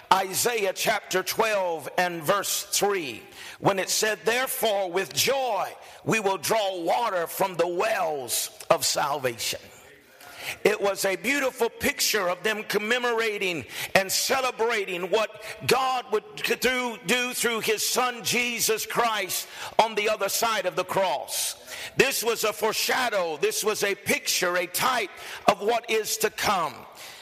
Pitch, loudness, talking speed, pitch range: 215 Hz, -25 LUFS, 135 wpm, 195-235 Hz